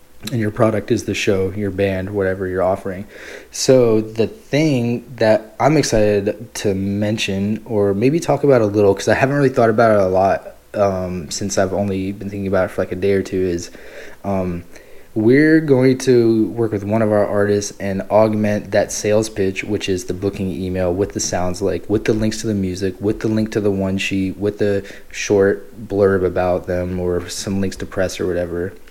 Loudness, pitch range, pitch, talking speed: -18 LUFS, 95-110 Hz, 100 Hz, 205 wpm